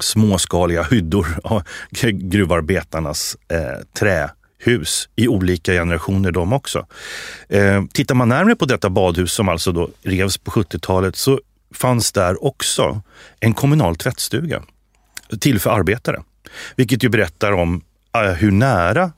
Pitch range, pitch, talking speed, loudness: 90-120 Hz, 100 Hz, 130 wpm, -18 LUFS